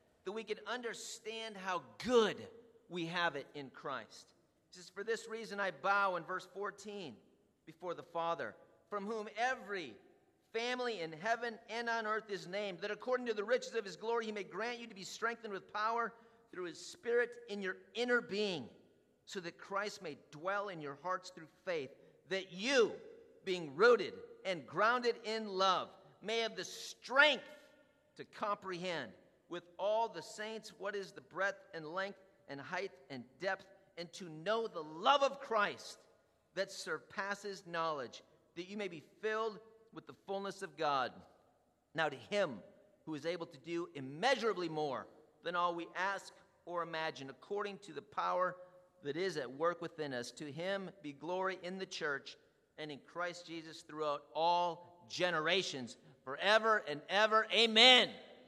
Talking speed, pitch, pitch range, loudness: 165 wpm, 195 Hz, 170-225 Hz, -37 LUFS